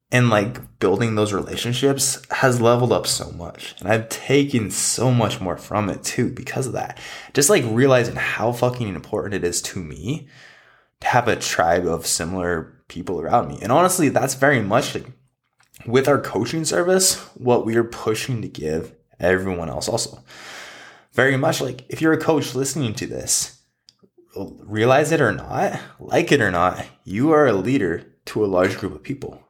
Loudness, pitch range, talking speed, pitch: -20 LUFS, 105-135 Hz, 180 wpm, 125 Hz